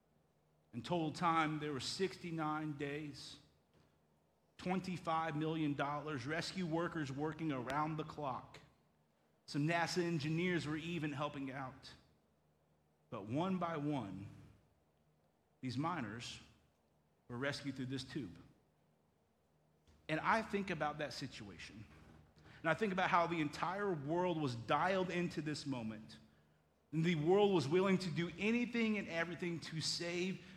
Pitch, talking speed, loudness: 150 Hz, 130 wpm, -39 LUFS